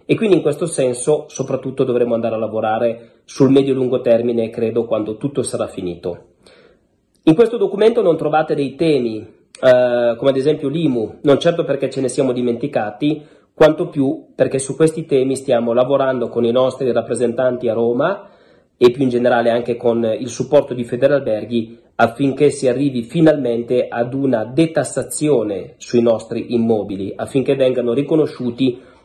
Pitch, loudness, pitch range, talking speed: 130 Hz, -17 LUFS, 115-140 Hz, 155 wpm